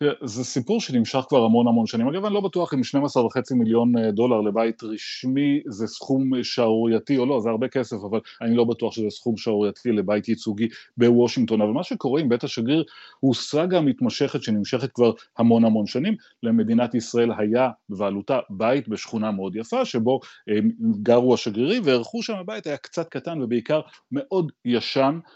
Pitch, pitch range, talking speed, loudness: 120 Hz, 115-145 Hz, 165 wpm, -23 LUFS